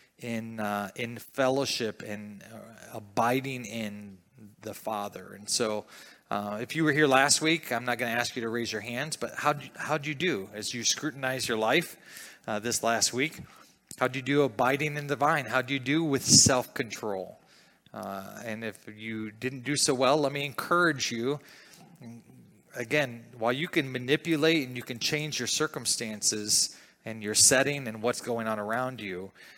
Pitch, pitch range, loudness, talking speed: 125 Hz, 110-145 Hz, -28 LUFS, 185 wpm